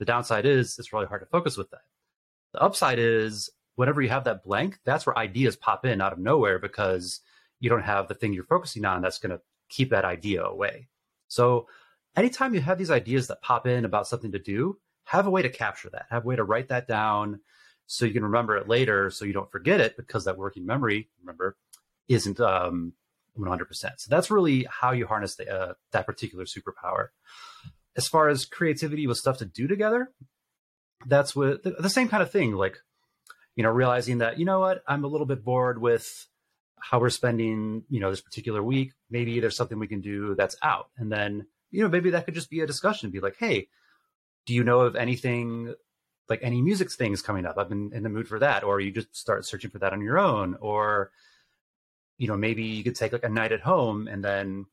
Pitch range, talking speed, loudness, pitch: 105-135 Hz, 220 wpm, -26 LUFS, 120 Hz